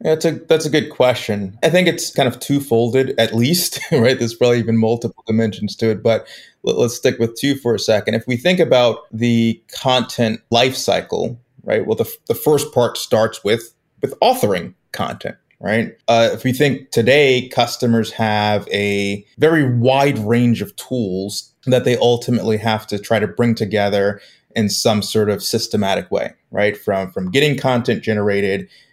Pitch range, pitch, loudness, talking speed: 110-130 Hz, 115 Hz, -17 LUFS, 180 wpm